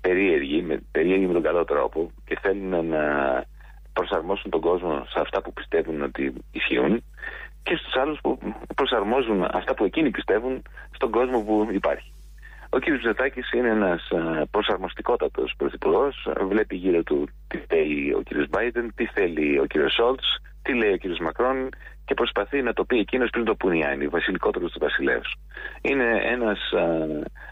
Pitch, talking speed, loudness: 100 Hz, 155 wpm, -24 LUFS